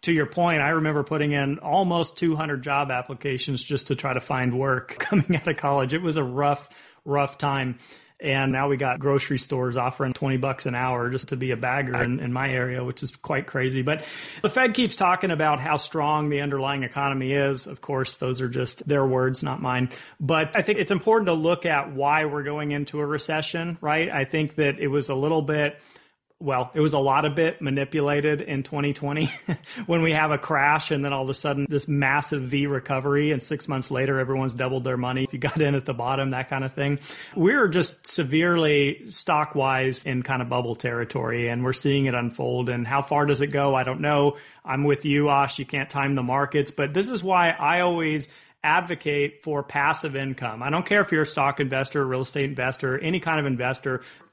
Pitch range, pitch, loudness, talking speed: 130-150 Hz, 140 Hz, -24 LUFS, 220 wpm